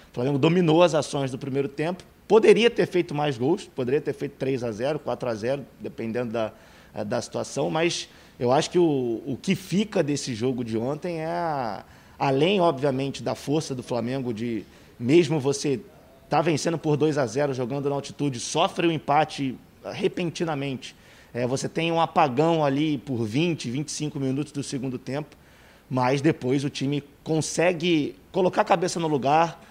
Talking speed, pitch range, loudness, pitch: 170 wpm, 135-165 Hz, -25 LUFS, 145 Hz